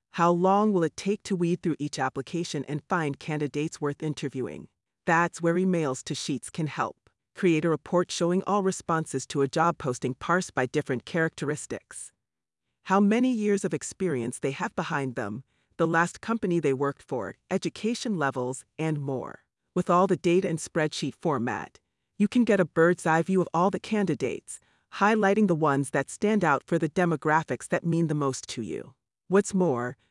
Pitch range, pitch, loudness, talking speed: 145-185 Hz, 165 Hz, -27 LUFS, 180 wpm